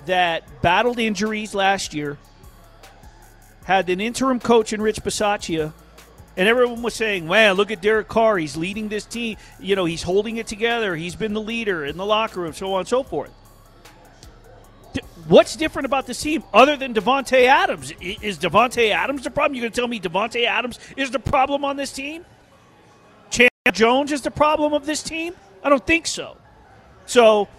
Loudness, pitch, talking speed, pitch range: -20 LUFS, 220 Hz, 185 wpm, 195-260 Hz